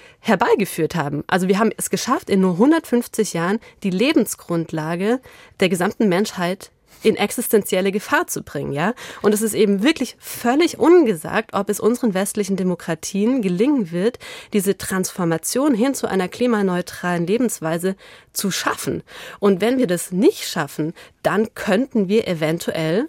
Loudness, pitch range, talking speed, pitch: -20 LUFS, 180-235 Hz, 145 wpm, 205 Hz